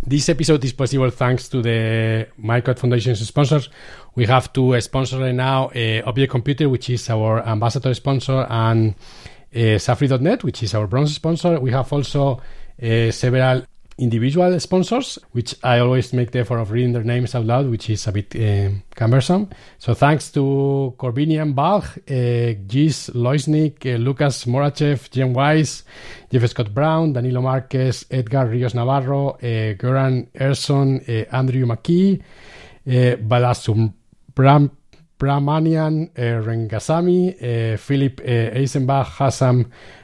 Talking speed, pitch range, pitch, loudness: 140 wpm, 120-140 Hz, 130 Hz, -19 LUFS